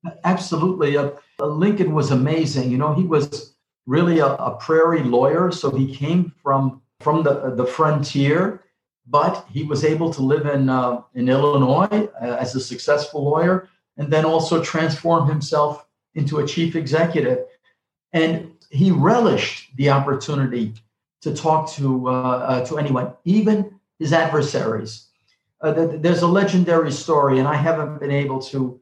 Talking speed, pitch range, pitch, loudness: 150 wpm, 135-165 Hz, 150 Hz, -20 LUFS